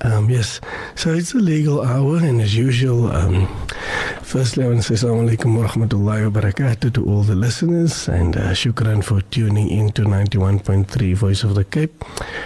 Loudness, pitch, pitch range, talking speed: -18 LUFS, 115 Hz, 100-125 Hz, 165 wpm